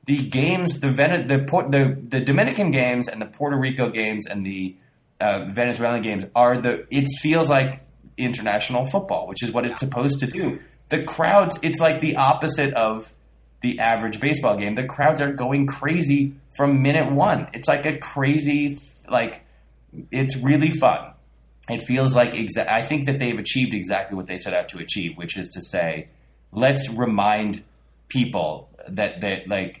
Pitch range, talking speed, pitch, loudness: 110-140 Hz, 175 wpm, 130 Hz, -22 LUFS